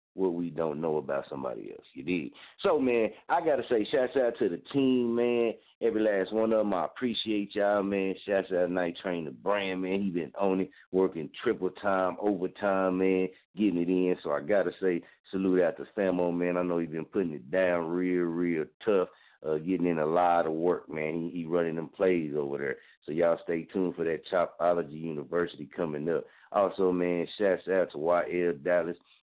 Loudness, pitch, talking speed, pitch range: -29 LUFS, 90 Hz, 205 wpm, 85-95 Hz